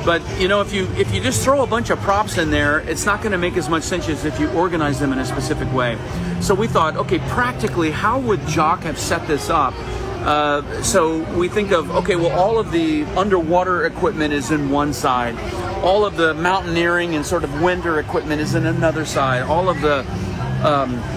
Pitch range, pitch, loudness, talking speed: 145-180 Hz, 160 Hz, -19 LUFS, 220 wpm